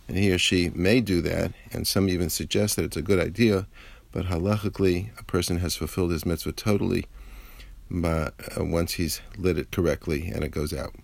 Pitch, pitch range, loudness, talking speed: 90 Hz, 85-105 Hz, -26 LUFS, 195 wpm